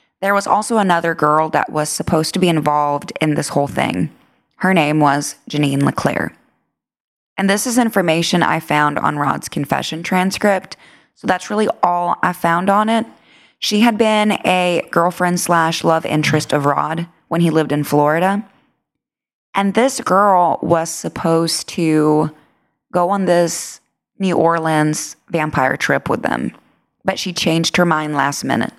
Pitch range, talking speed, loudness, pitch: 155-190 Hz, 155 wpm, -16 LUFS, 170 Hz